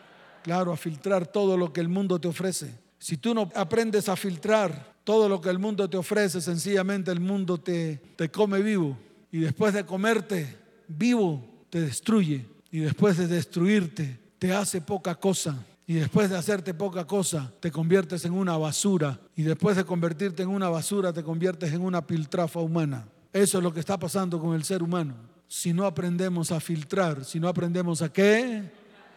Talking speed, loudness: 185 wpm, -27 LUFS